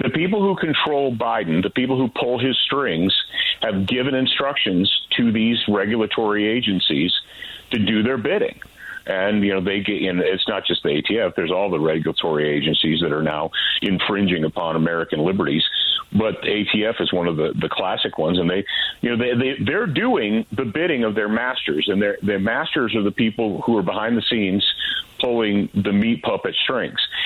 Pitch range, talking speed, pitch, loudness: 100-125 Hz, 185 wpm, 110 Hz, -20 LUFS